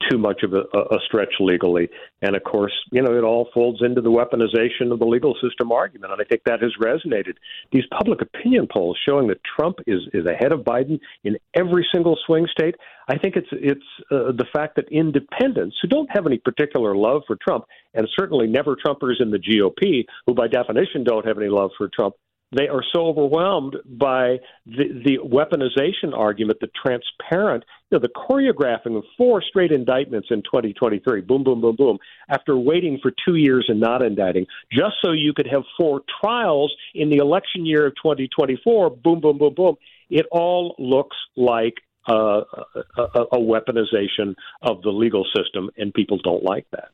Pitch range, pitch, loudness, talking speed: 120-160 Hz, 130 Hz, -20 LUFS, 185 wpm